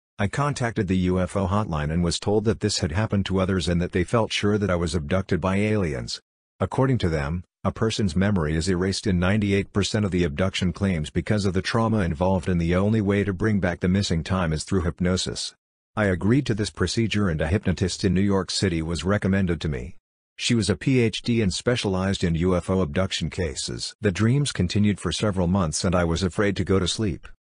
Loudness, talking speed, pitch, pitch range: -24 LUFS, 210 wpm, 95 Hz, 90-105 Hz